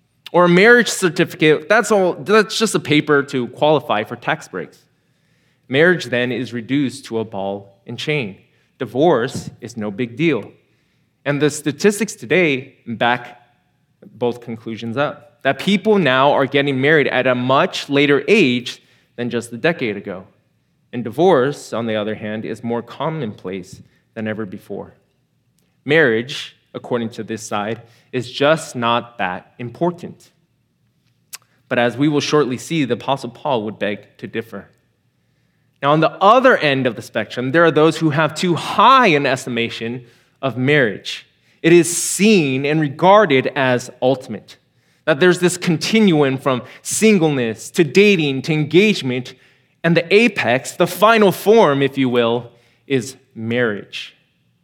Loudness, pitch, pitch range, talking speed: -17 LUFS, 135 Hz, 120-165 Hz, 150 wpm